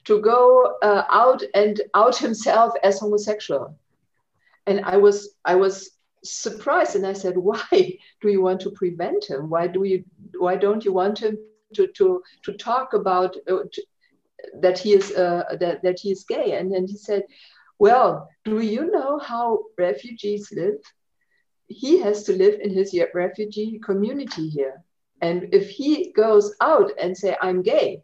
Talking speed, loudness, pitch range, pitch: 165 wpm, -21 LUFS, 185-240 Hz, 205 Hz